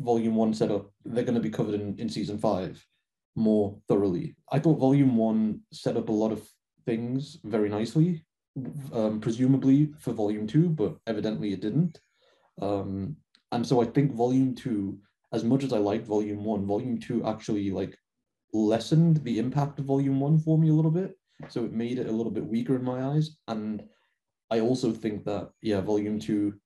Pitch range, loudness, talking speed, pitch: 105-135 Hz, -27 LUFS, 185 wpm, 115 Hz